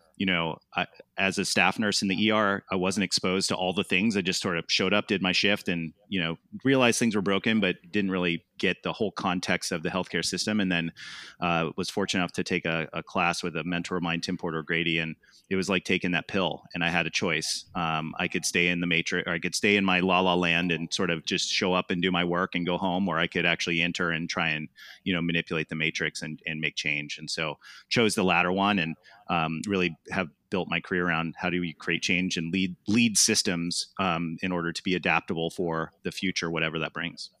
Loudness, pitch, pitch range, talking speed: -27 LUFS, 90 Hz, 85-95 Hz, 250 wpm